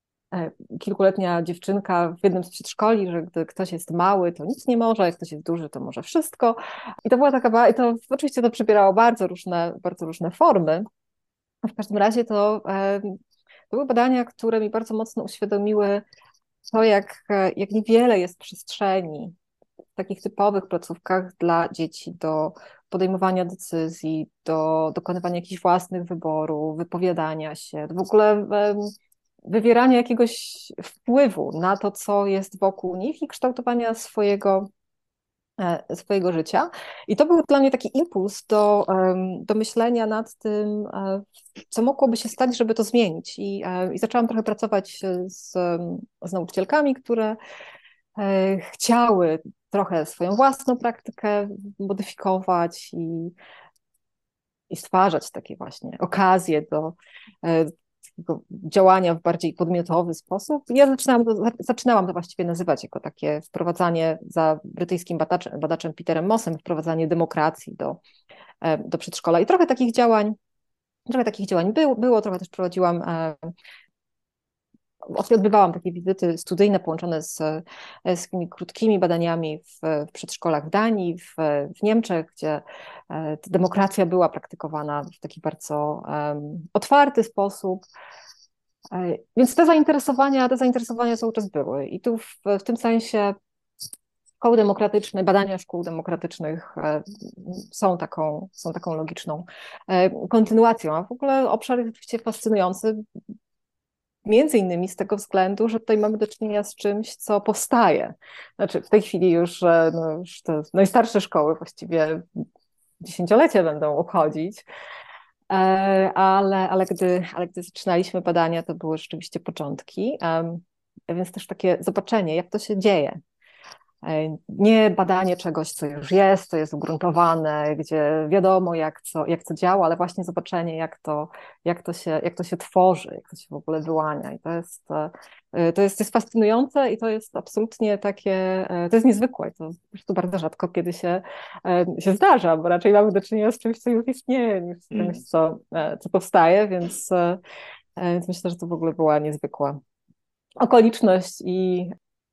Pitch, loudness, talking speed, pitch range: 190 Hz, -22 LUFS, 145 wpm, 170-215 Hz